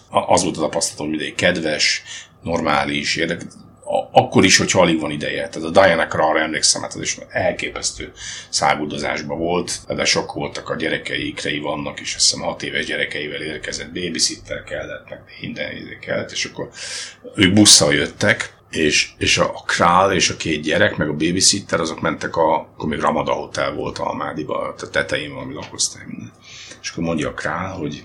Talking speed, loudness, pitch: 175 wpm, -18 LUFS, 85 Hz